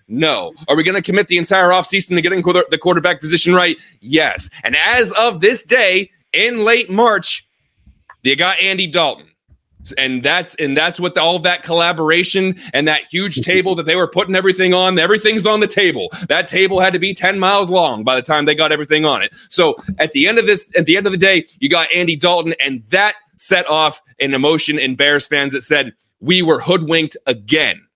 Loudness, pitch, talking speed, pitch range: -14 LUFS, 175 Hz, 210 wpm, 155-190 Hz